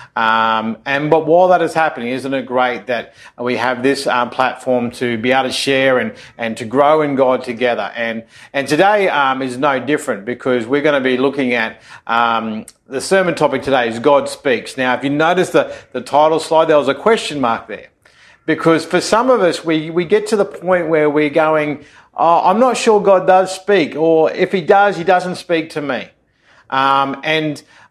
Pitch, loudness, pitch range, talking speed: 145 Hz, -15 LUFS, 125-170 Hz, 205 wpm